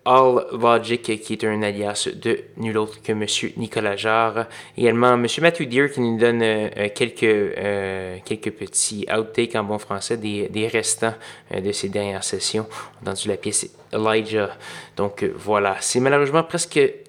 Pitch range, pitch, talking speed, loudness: 105-120 Hz, 110 Hz, 170 wpm, -21 LUFS